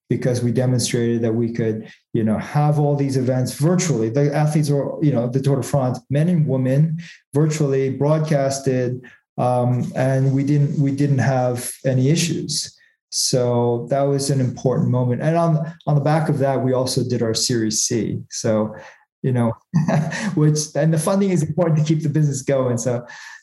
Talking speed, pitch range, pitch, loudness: 180 wpm, 125-155 Hz, 135 Hz, -19 LUFS